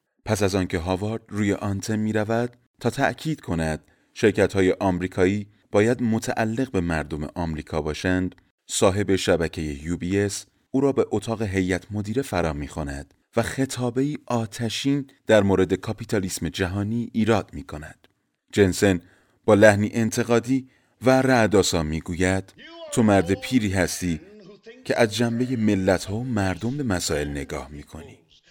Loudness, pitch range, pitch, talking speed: -23 LUFS, 90-120 Hz, 105 Hz, 140 wpm